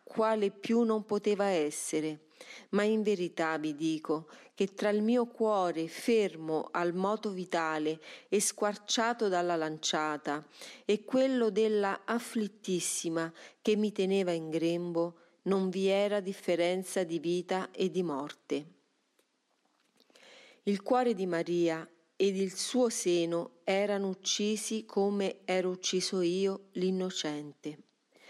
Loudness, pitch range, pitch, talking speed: -32 LUFS, 170-210 Hz, 190 Hz, 120 wpm